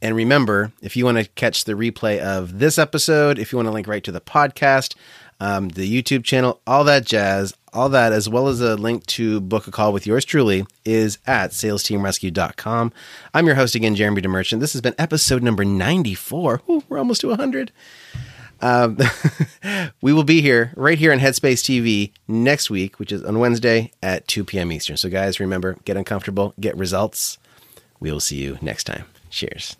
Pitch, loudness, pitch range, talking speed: 115 Hz, -19 LUFS, 100-135 Hz, 195 wpm